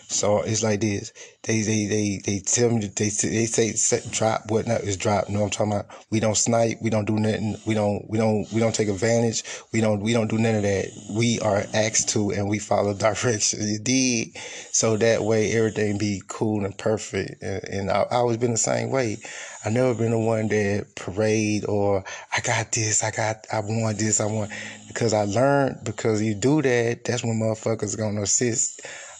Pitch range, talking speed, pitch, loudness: 105-115 Hz, 210 wpm, 110 Hz, -23 LUFS